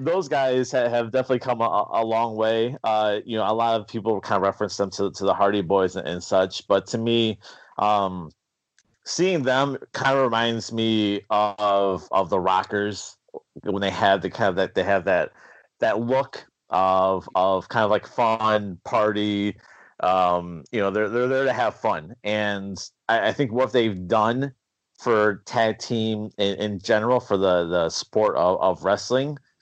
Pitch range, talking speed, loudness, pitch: 100-120 Hz, 180 wpm, -23 LUFS, 110 Hz